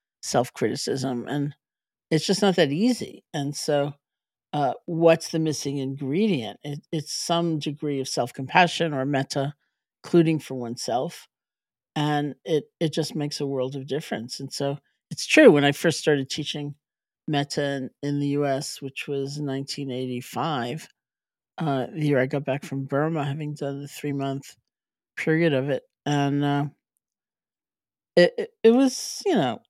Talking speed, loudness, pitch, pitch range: 150 wpm, -25 LUFS, 145 Hz, 135-160 Hz